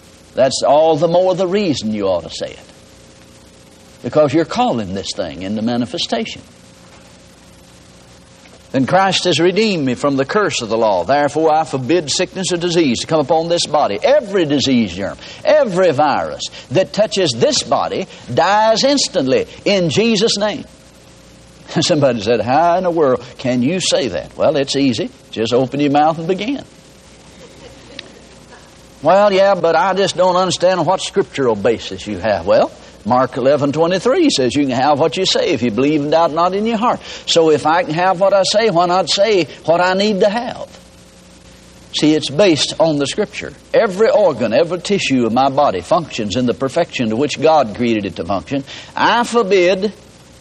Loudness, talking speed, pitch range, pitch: -15 LUFS, 175 wpm, 130-195 Hz, 165 Hz